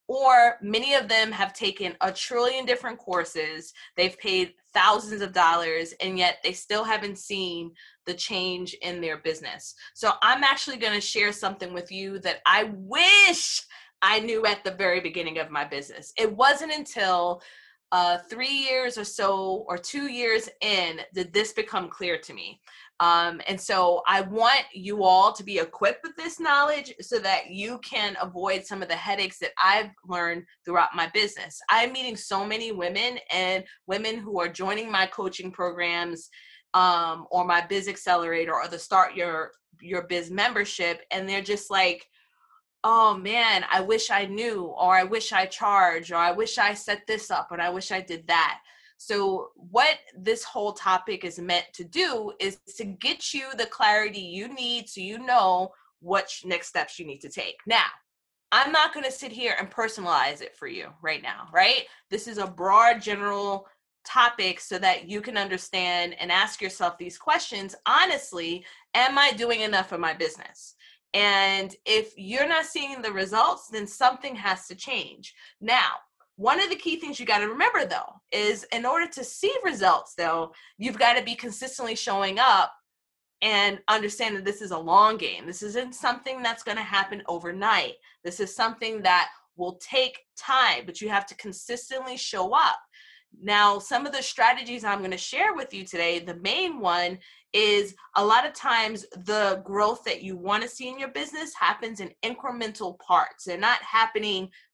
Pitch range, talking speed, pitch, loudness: 185-240 Hz, 180 wpm, 205 Hz, -24 LUFS